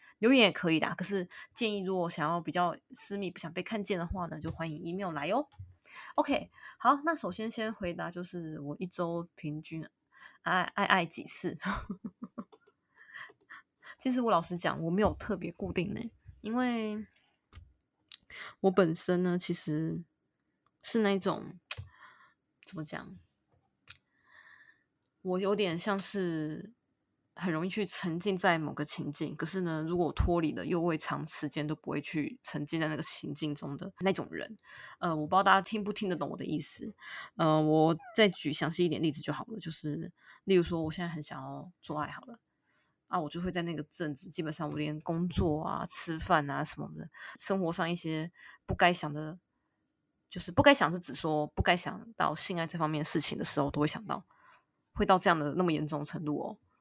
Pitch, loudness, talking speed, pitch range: 175 Hz, -32 LUFS, 260 characters per minute, 155-195 Hz